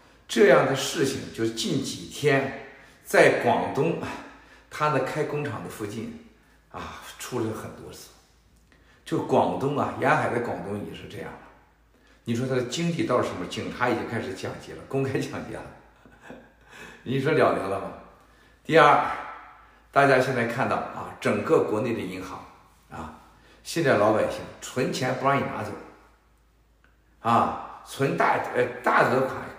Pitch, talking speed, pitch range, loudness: 130 Hz, 205 characters per minute, 110-140 Hz, -25 LUFS